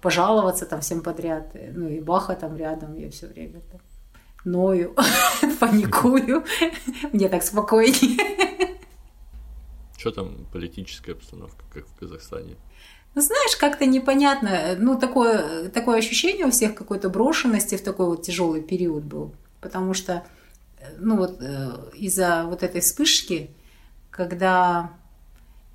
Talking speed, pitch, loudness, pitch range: 120 wpm, 180 Hz, -21 LUFS, 155-235 Hz